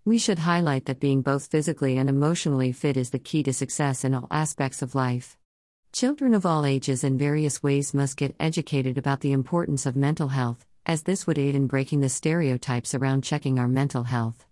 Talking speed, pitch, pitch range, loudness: 205 wpm, 140 Hz, 130-155 Hz, -25 LUFS